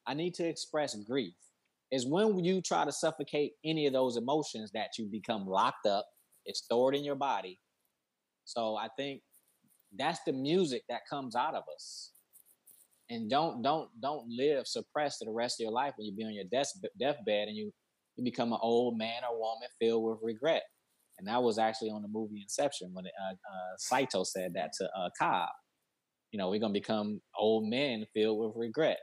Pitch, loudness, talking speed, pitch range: 115 Hz, -34 LUFS, 195 wpm, 110-145 Hz